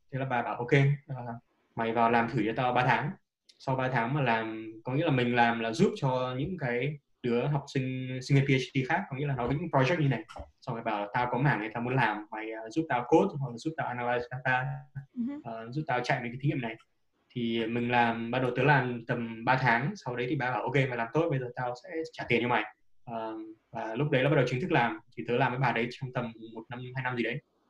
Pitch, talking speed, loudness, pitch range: 125 Hz, 275 wpm, -30 LUFS, 115-140 Hz